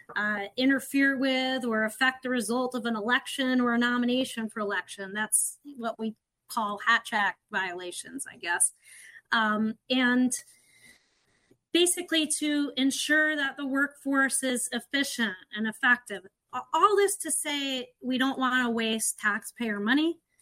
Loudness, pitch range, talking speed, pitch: -27 LUFS, 225-275 Hz, 140 wpm, 250 Hz